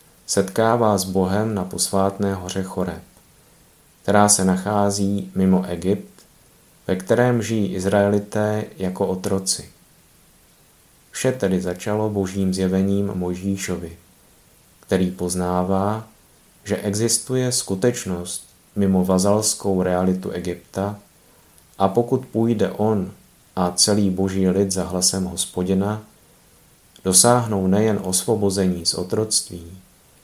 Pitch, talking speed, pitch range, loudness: 95 Hz, 95 wpm, 90-105 Hz, -21 LUFS